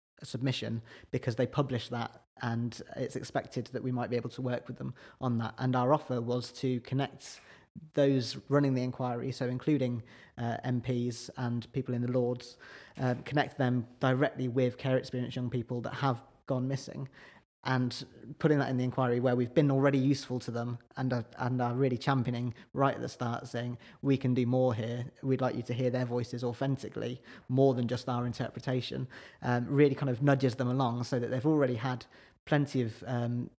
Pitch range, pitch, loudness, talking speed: 120-135 Hz, 125 Hz, -32 LUFS, 195 wpm